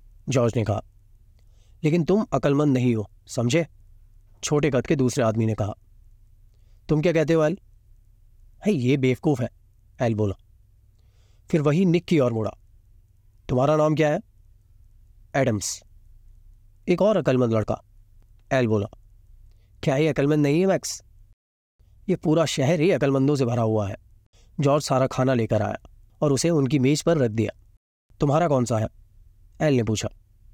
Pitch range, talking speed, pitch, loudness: 100-140 Hz, 145 wpm, 110 Hz, -23 LUFS